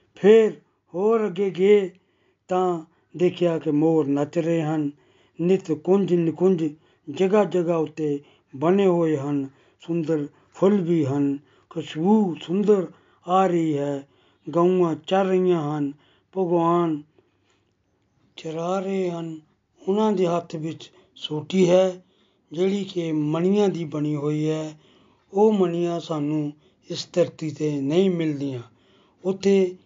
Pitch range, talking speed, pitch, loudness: 155-185 Hz, 115 wpm, 170 Hz, -23 LUFS